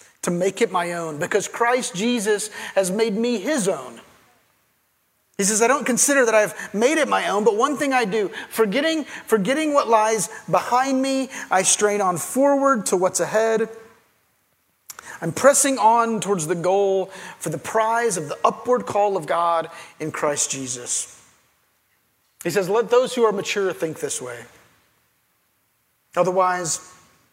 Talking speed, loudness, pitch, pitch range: 155 wpm, -21 LUFS, 215 Hz, 185-240 Hz